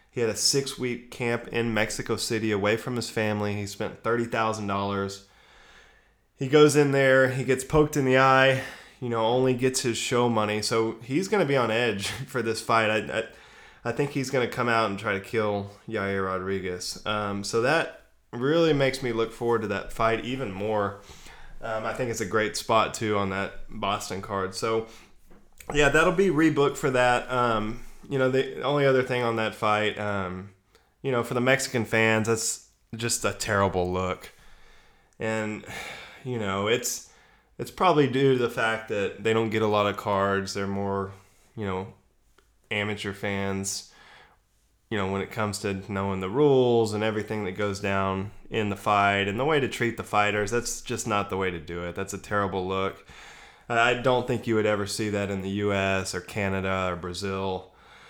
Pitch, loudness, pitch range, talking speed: 110 Hz, -26 LUFS, 100-120 Hz, 195 wpm